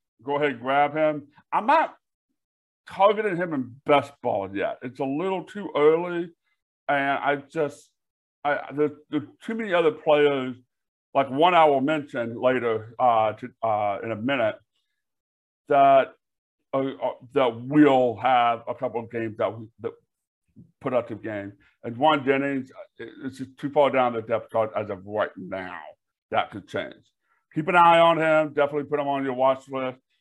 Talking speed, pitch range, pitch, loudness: 165 wpm, 120-150 Hz, 140 Hz, -24 LUFS